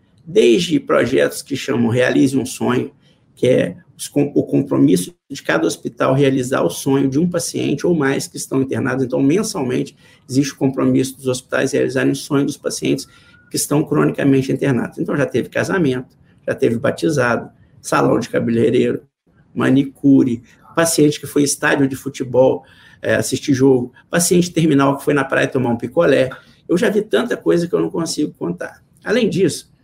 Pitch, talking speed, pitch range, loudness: 135 Hz, 165 wpm, 130-140 Hz, -17 LUFS